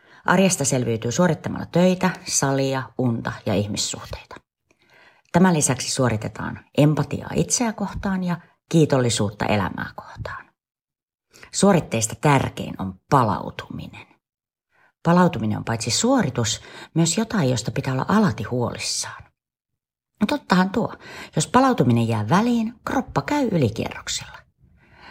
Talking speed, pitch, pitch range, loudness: 105 wpm, 150 Hz, 120-190 Hz, -21 LUFS